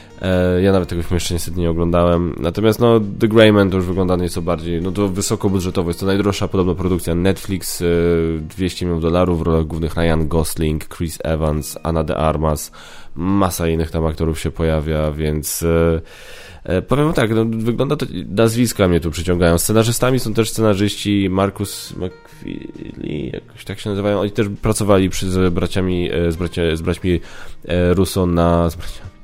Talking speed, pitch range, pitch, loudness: 160 wpm, 85-100 Hz, 90 Hz, -18 LUFS